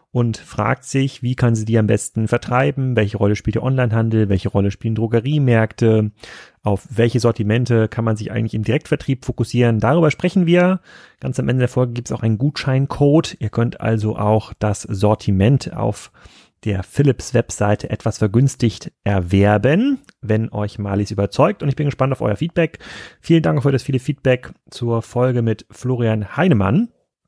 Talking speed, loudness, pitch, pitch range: 170 wpm, -18 LUFS, 115 Hz, 110-135 Hz